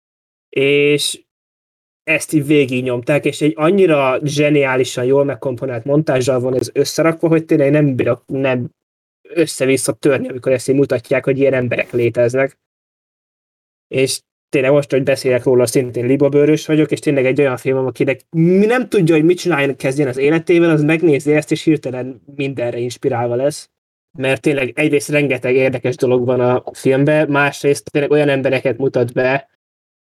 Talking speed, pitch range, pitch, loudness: 150 wpm, 130-150 Hz, 135 Hz, -15 LUFS